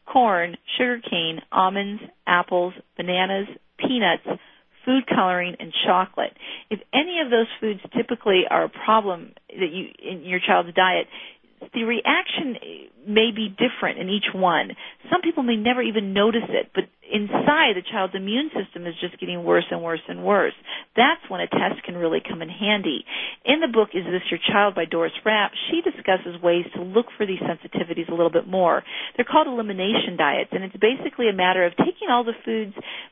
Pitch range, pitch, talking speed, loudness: 180-245 Hz, 210 Hz, 180 wpm, -22 LUFS